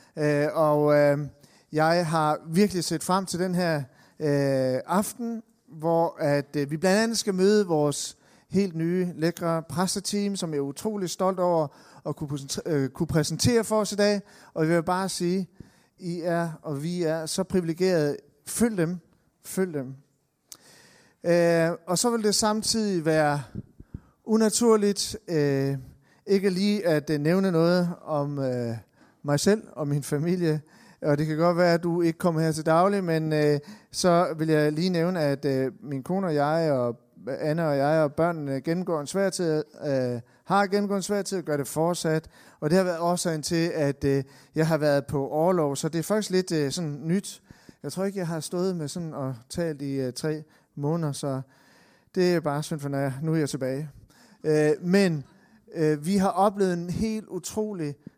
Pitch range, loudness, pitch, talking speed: 145-185 Hz, -26 LUFS, 165 Hz, 180 wpm